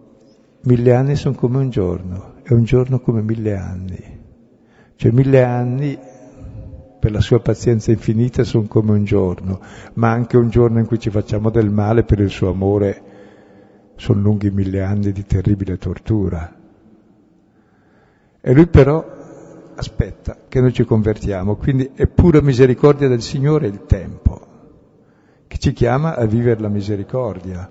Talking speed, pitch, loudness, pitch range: 145 wpm, 110 Hz, -16 LUFS, 100-125 Hz